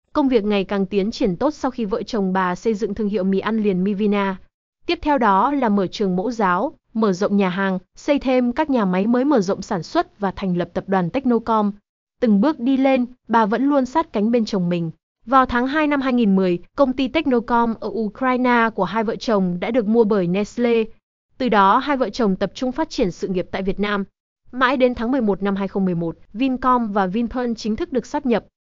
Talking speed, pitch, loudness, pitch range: 225 wpm, 225 Hz, -20 LUFS, 195-255 Hz